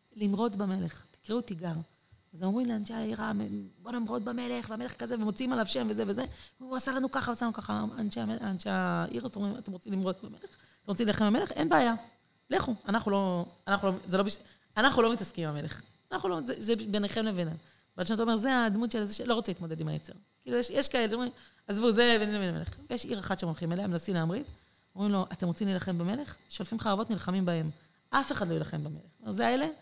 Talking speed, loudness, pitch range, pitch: 165 wpm, -32 LUFS, 180-235 Hz, 205 Hz